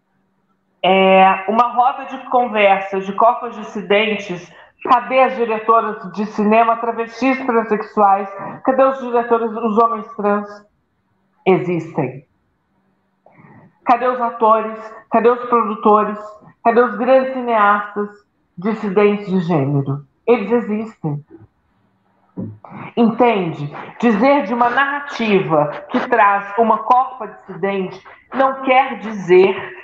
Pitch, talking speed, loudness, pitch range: 215 Hz, 100 wpm, -16 LUFS, 190-240 Hz